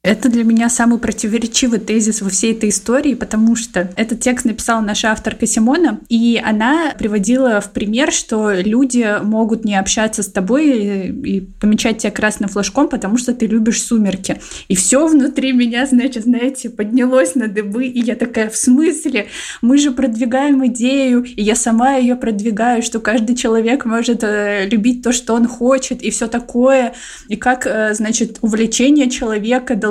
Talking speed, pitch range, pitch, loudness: 165 wpm, 220-255 Hz, 235 Hz, -15 LUFS